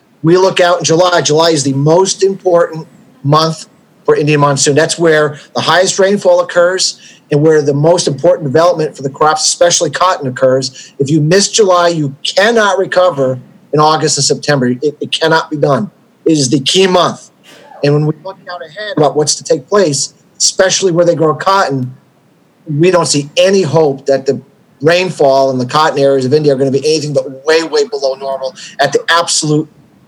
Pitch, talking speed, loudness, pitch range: 160 Hz, 190 wpm, -11 LUFS, 145-180 Hz